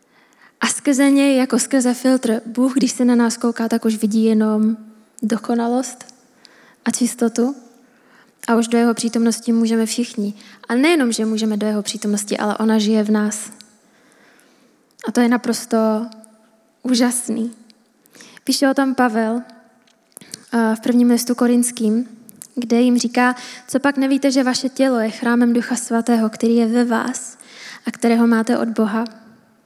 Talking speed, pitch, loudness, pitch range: 150 wpm, 235 Hz, -18 LUFS, 225-250 Hz